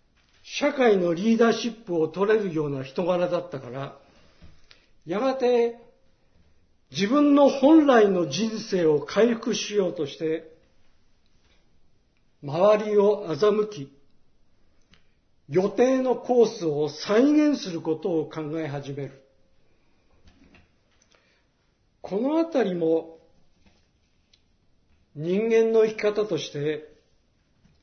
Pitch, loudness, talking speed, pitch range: 175 Hz, -23 LUFS, 180 characters per minute, 140-225 Hz